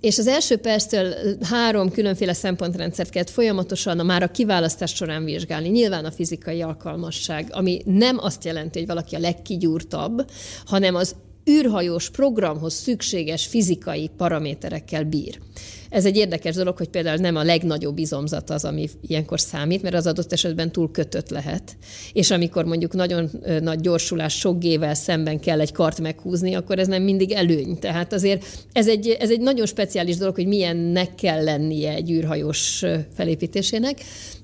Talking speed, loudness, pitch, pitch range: 155 wpm, -22 LUFS, 175 Hz, 160-195 Hz